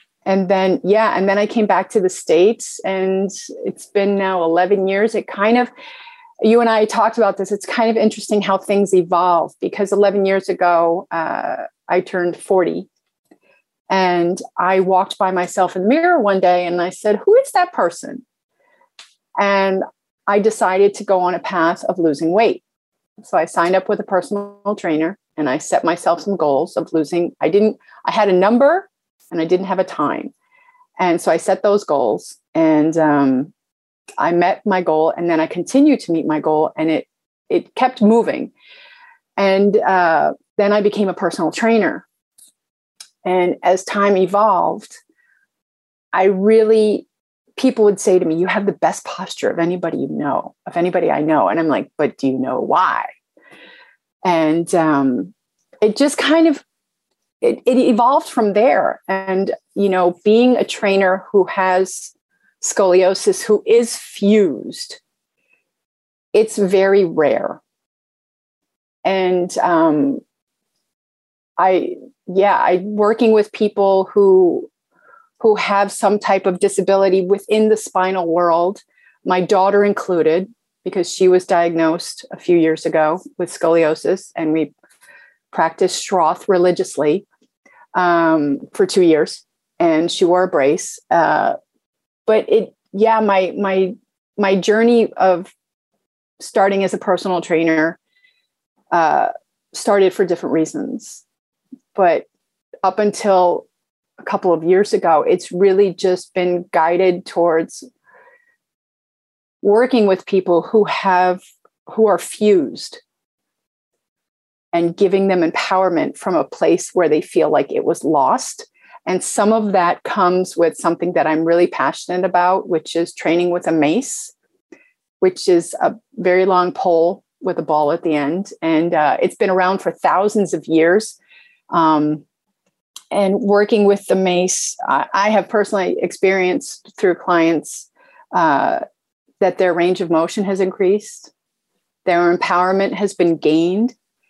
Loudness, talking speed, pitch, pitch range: -16 LUFS, 145 wpm, 195 Hz, 180-225 Hz